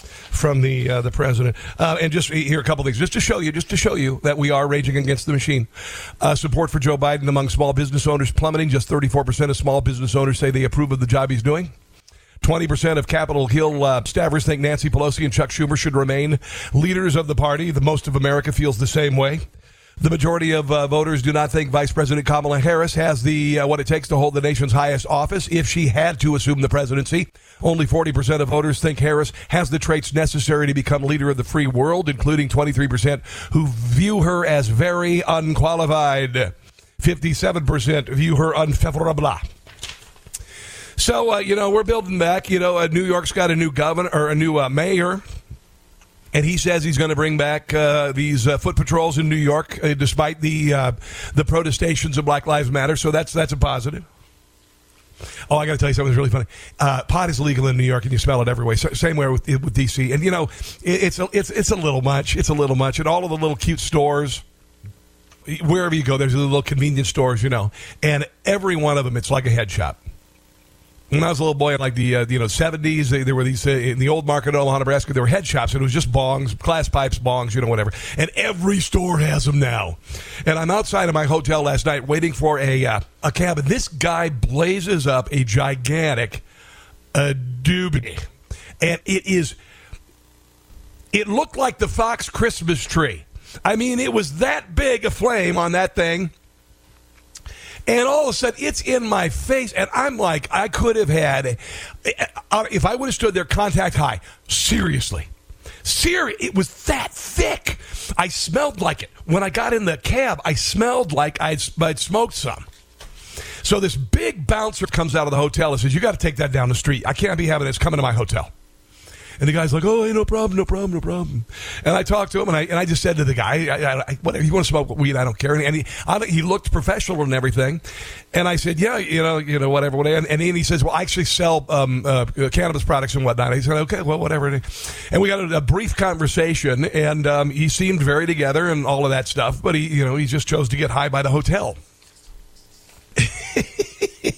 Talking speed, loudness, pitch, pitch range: 220 wpm, -19 LUFS, 150 Hz, 135-165 Hz